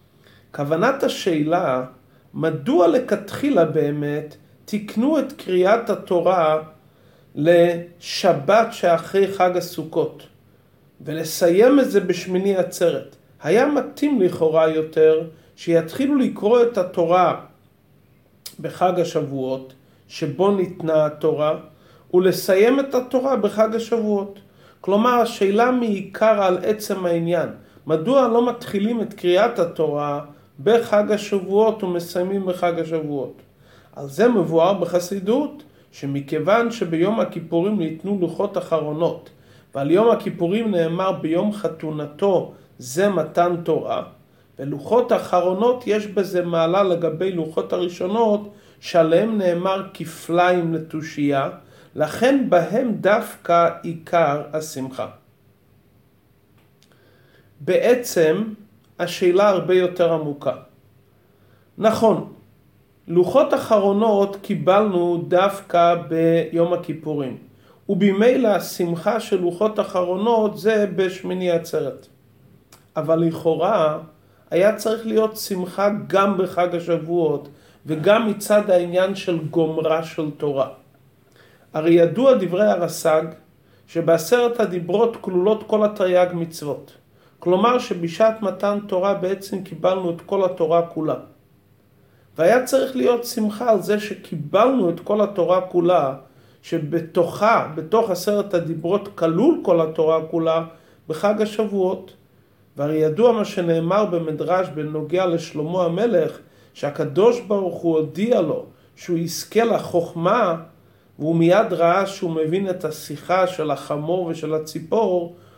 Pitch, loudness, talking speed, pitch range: 175 Hz, -20 LUFS, 100 wpm, 155-200 Hz